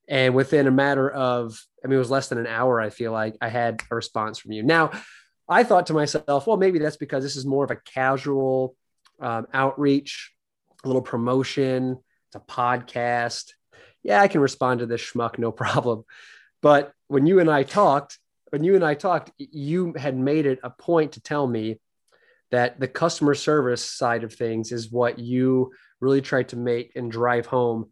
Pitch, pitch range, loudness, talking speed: 130 Hz, 120-145 Hz, -23 LUFS, 195 wpm